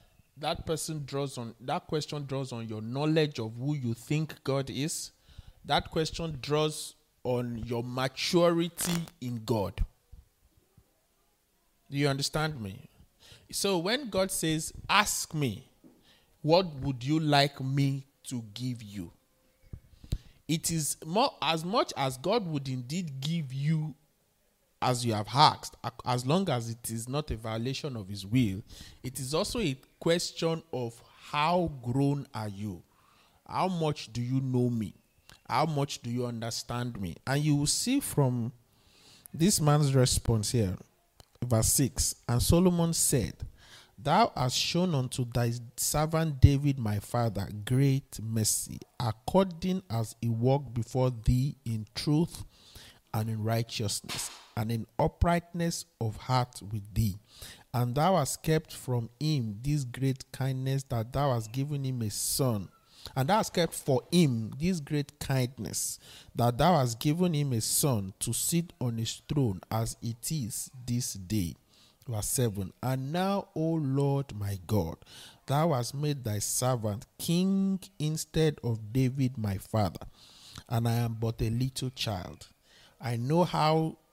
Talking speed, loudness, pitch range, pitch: 145 wpm, -30 LUFS, 115-150 Hz, 130 Hz